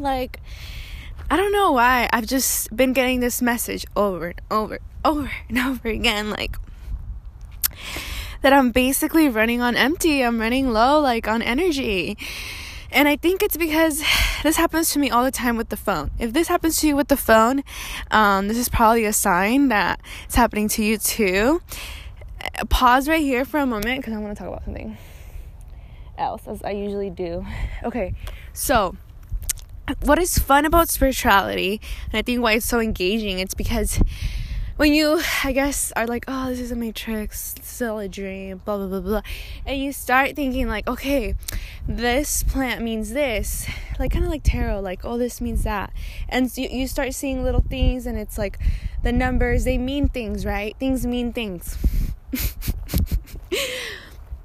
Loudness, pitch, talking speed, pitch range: -21 LUFS, 240 Hz, 175 wpm, 205-270 Hz